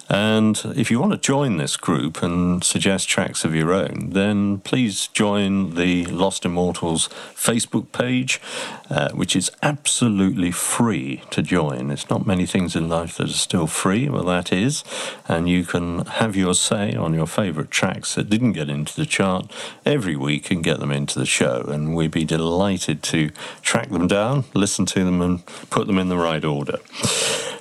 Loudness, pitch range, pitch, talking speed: -21 LUFS, 80-100 Hz, 90 Hz, 185 wpm